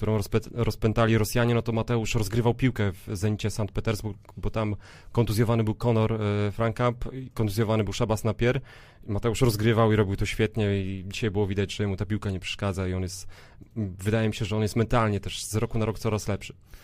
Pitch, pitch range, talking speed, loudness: 110 Hz, 105-115 Hz, 200 wpm, -27 LUFS